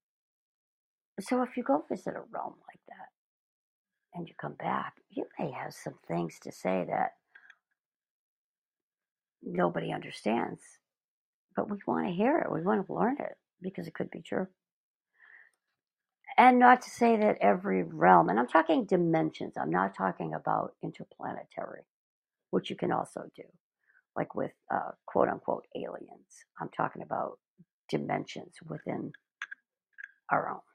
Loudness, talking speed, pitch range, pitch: -30 LUFS, 140 wpm, 160-250 Hz, 195 Hz